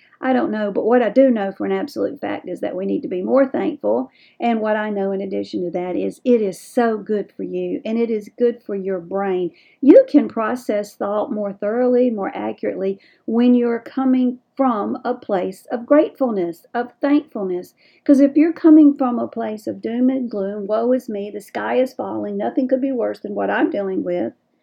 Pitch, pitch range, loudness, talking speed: 230 Hz, 195-260 Hz, -19 LUFS, 210 wpm